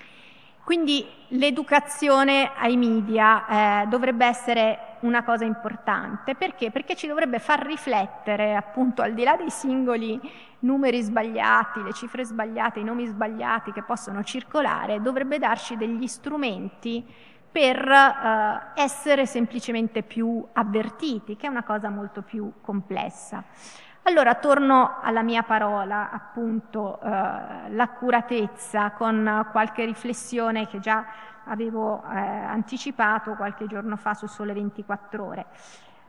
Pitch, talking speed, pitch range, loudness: 230 Hz, 120 wpm, 215-255 Hz, -24 LUFS